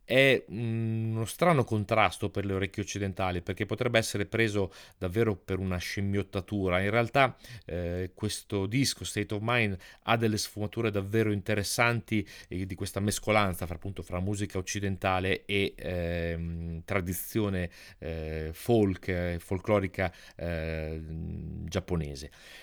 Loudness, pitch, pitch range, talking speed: -30 LUFS, 100 Hz, 90-110 Hz, 120 wpm